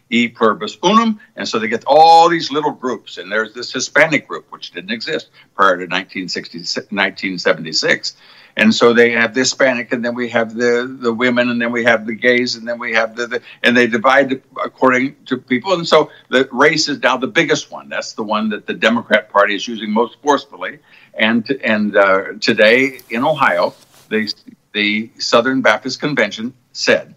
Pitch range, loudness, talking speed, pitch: 115-135 Hz, -15 LUFS, 190 wpm, 120 Hz